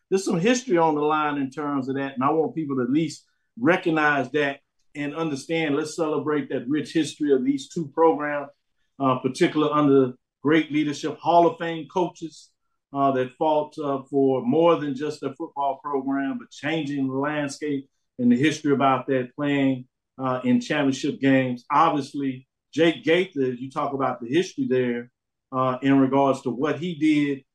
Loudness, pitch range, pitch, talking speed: -24 LUFS, 135-155 Hz, 145 Hz, 175 wpm